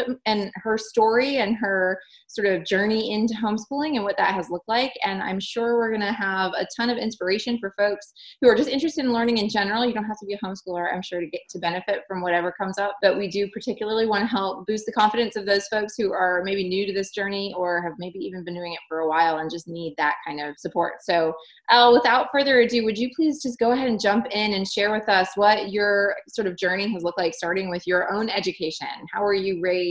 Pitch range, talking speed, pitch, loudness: 185-225 Hz, 255 wpm, 200 Hz, -23 LUFS